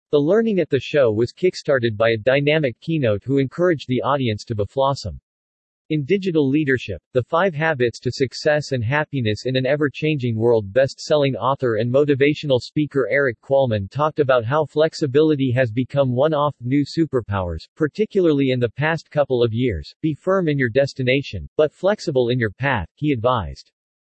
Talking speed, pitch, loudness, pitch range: 175 wpm, 135 Hz, -20 LUFS, 120-150 Hz